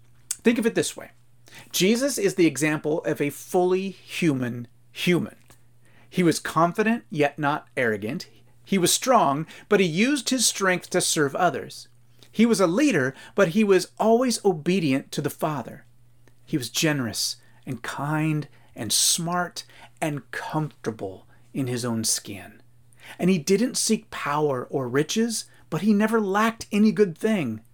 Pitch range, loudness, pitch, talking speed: 120-195 Hz, -23 LUFS, 155 Hz, 150 wpm